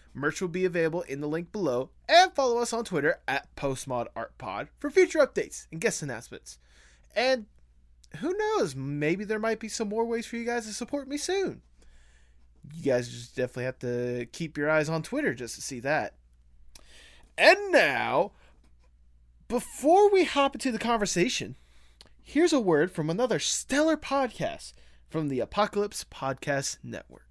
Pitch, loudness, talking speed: 160 Hz, -27 LUFS, 160 wpm